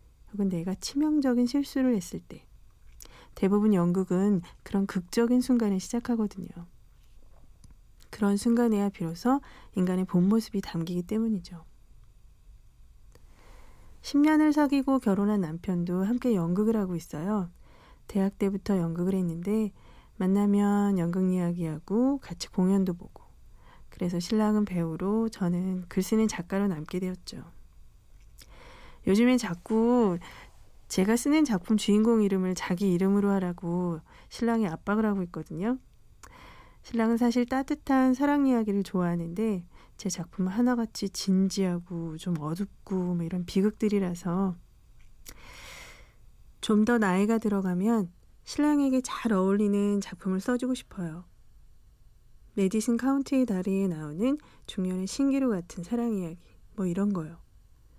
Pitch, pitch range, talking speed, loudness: 200 Hz, 180-230 Hz, 275 characters per minute, -28 LUFS